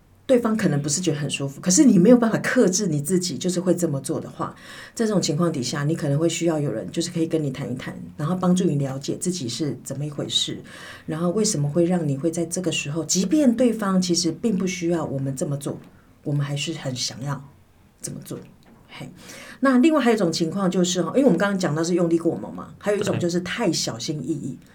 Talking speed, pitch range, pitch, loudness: 355 characters per minute, 150-185 Hz, 170 Hz, -22 LUFS